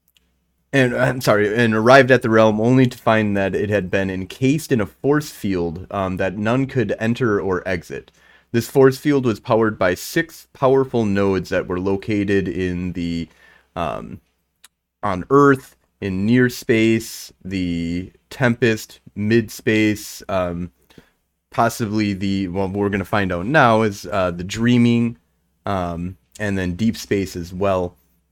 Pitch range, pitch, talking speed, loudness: 90-120 Hz, 100 Hz, 155 wpm, -19 LUFS